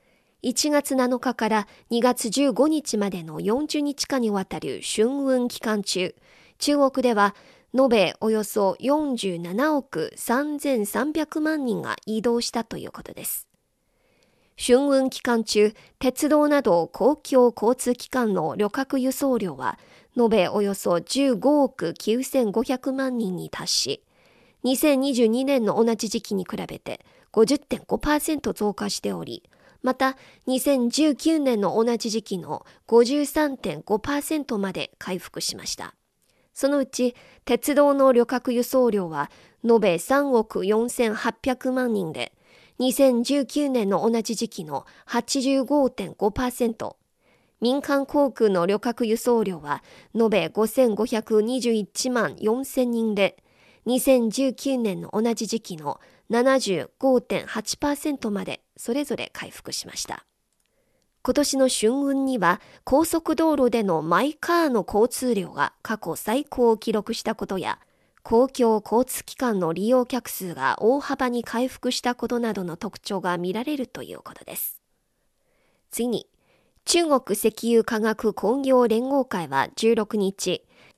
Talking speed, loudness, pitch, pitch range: 190 characters per minute, -23 LUFS, 235 Hz, 215-265 Hz